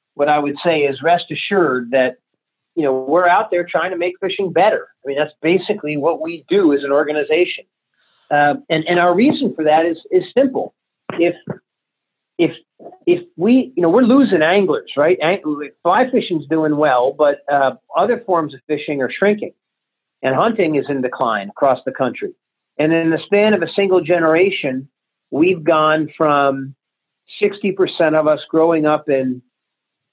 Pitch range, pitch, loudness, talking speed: 145-190 Hz, 160 Hz, -16 LUFS, 170 wpm